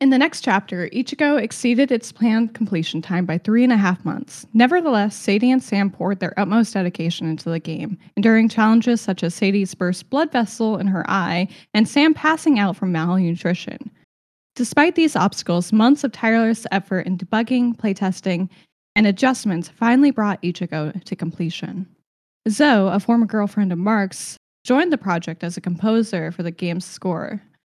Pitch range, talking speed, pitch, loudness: 180-235 Hz, 165 wpm, 200 Hz, -19 LUFS